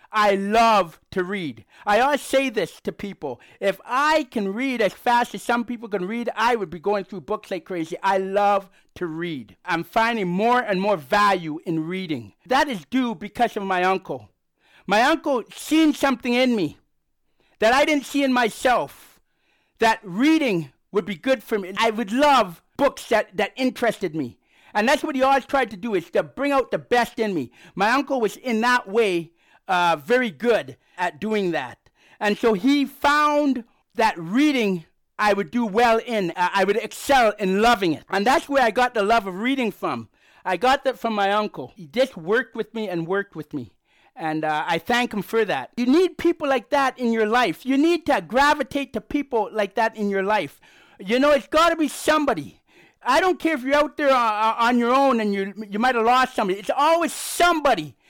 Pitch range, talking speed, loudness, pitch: 195-265 Hz, 205 wpm, -22 LUFS, 225 Hz